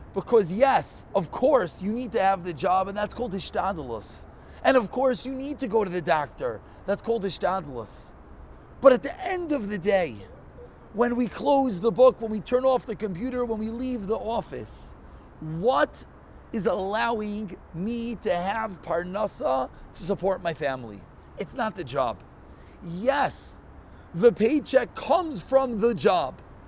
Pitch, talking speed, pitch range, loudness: 210 Hz, 160 wpm, 175-250 Hz, -26 LUFS